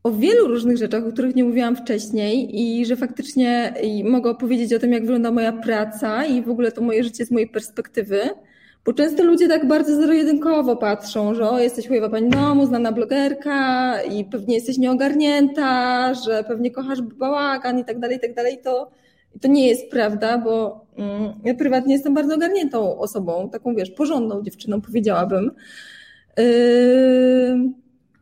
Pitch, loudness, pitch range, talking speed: 245 Hz, -19 LUFS, 225-265 Hz, 165 wpm